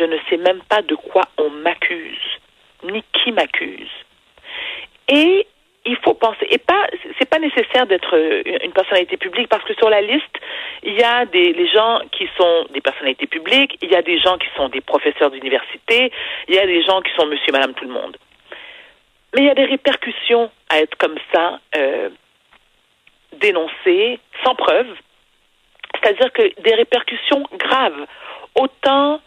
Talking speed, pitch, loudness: 170 wpm, 260 Hz, -16 LUFS